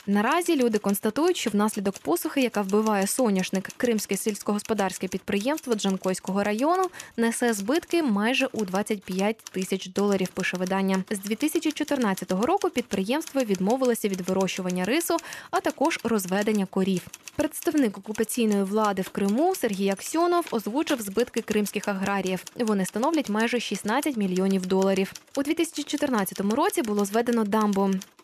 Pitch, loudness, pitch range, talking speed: 215 Hz, -26 LUFS, 195-270 Hz, 125 wpm